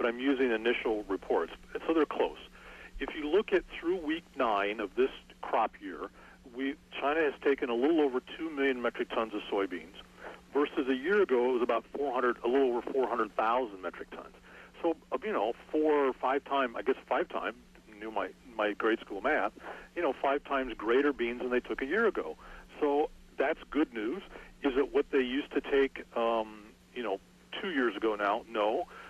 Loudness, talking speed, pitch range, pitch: -32 LUFS, 195 wpm, 120-165 Hz, 135 Hz